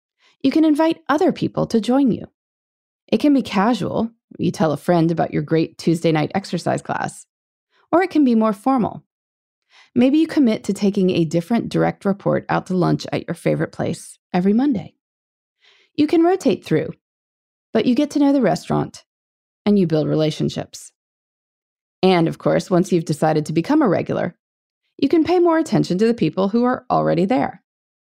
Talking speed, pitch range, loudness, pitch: 180 wpm, 170-285 Hz, -19 LUFS, 210 Hz